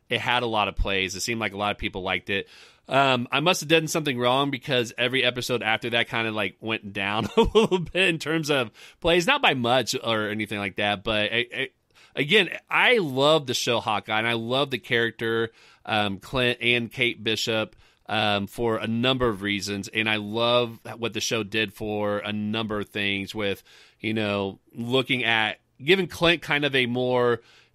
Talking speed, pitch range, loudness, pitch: 205 wpm, 105-125 Hz, -24 LUFS, 115 Hz